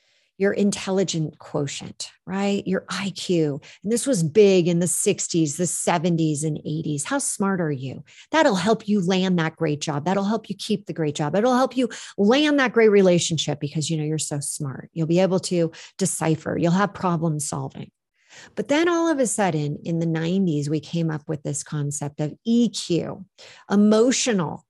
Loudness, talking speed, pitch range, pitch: -22 LUFS, 180 wpm, 155-205 Hz, 175 Hz